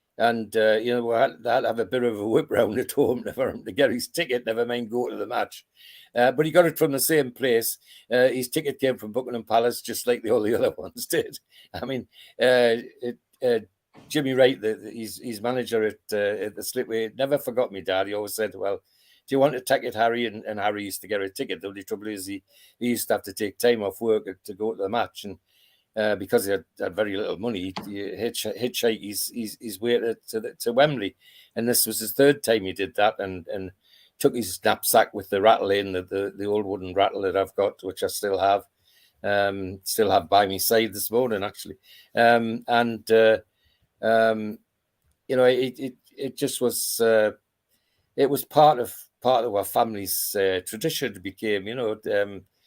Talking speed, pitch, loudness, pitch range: 220 wpm, 115 Hz, -24 LUFS, 105-125 Hz